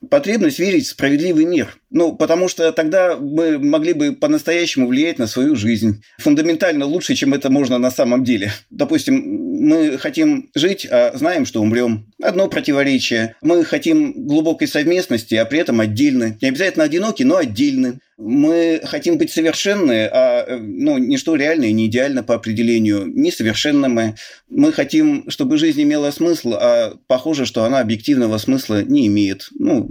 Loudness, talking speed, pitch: -16 LUFS, 155 wpm, 255 Hz